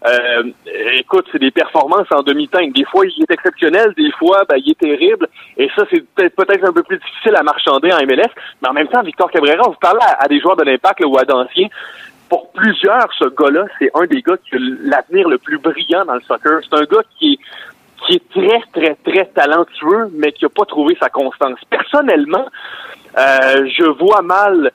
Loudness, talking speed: -13 LUFS, 220 wpm